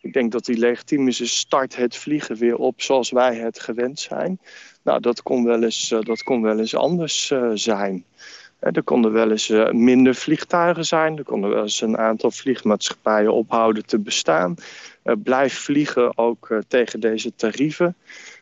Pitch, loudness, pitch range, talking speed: 120 Hz, -20 LUFS, 110-135 Hz, 160 wpm